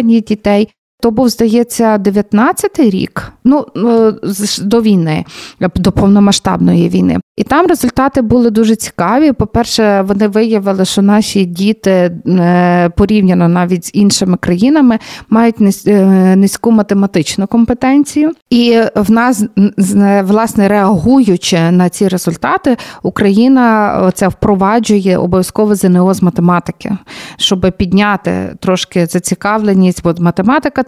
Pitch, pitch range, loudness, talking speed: 205 Hz, 185-230 Hz, -10 LUFS, 105 wpm